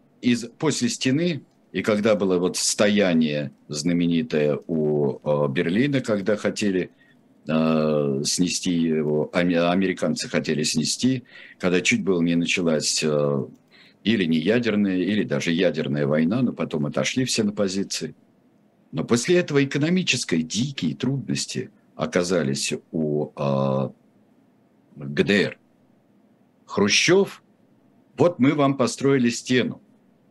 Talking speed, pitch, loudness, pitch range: 105 wpm, 90 Hz, -22 LUFS, 75-120 Hz